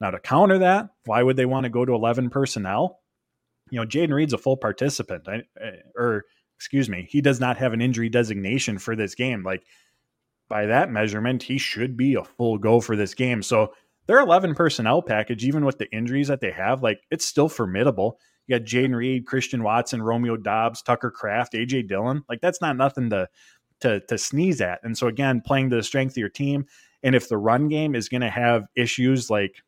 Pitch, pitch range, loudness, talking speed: 125 Hz, 115-135 Hz, -23 LUFS, 210 wpm